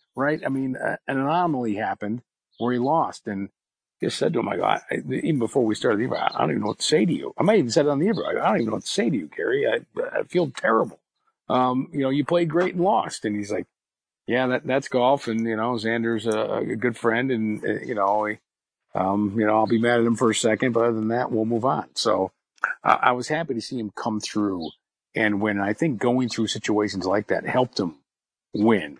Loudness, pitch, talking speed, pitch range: -24 LUFS, 115 Hz, 255 wpm, 105-130 Hz